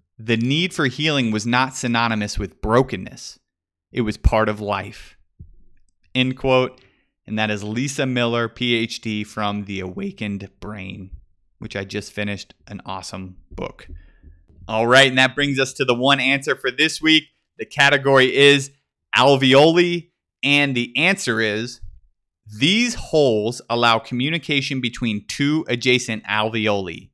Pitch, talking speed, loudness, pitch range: 115 Hz, 135 wpm, -19 LUFS, 100-135 Hz